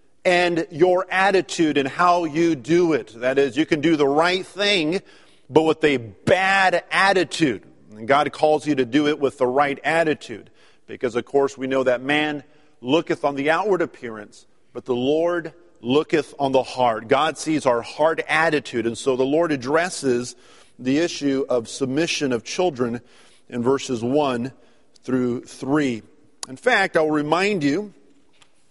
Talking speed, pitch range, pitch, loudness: 160 wpm, 130-165 Hz, 150 Hz, -21 LUFS